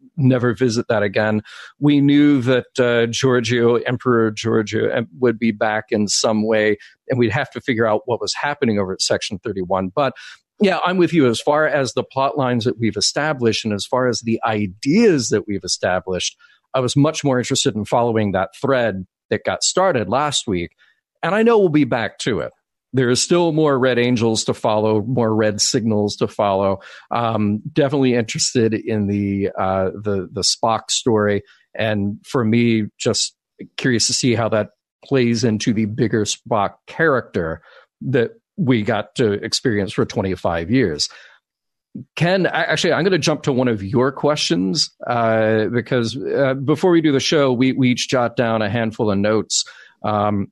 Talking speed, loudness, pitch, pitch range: 180 wpm, -18 LUFS, 120 Hz, 105-130 Hz